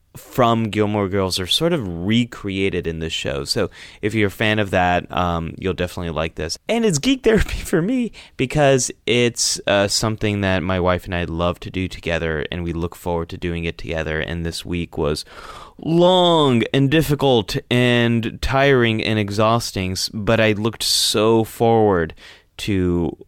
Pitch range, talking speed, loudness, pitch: 90-120 Hz, 170 wpm, -19 LUFS, 105 Hz